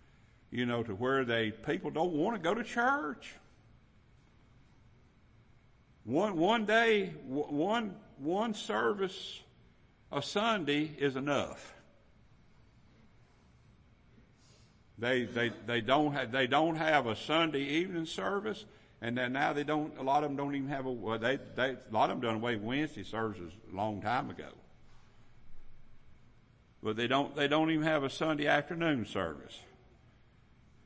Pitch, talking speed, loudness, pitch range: 135 Hz, 145 wpm, -33 LUFS, 115-155 Hz